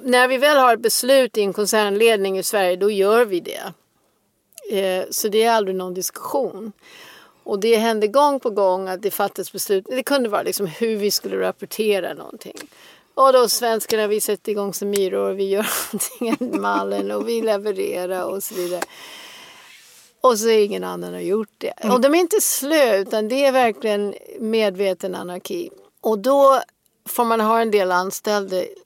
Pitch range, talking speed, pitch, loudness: 195-245 Hz, 180 wpm, 210 Hz, -19 LUFS